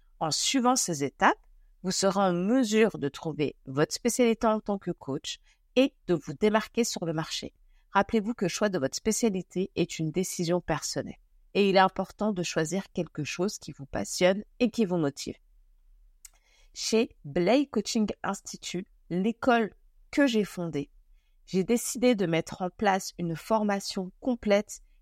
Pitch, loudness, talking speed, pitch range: 195 Hz, -28 LUFS, 160 wpm, 170-220 Hz